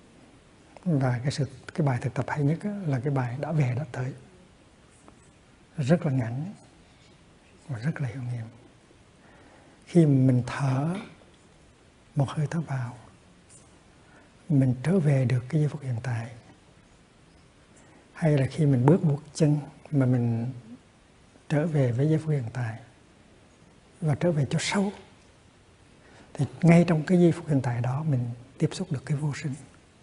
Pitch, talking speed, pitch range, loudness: 140 Hz, 155 wpm, 125-155 Hz, -26 LUFS